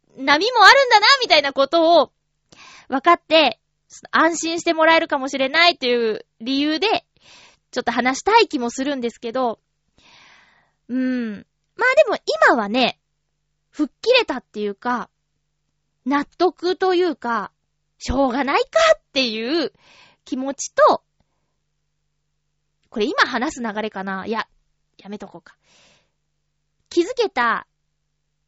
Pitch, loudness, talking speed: 255 Hz, -18 LUFS, 250 characters per minute